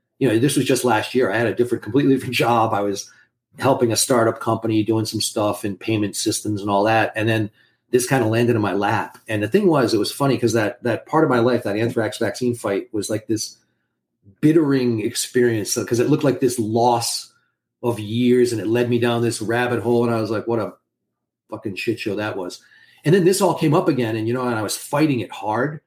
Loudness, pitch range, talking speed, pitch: -20 LUFS, 110-125 Hz, 245 wpm, 115 Hz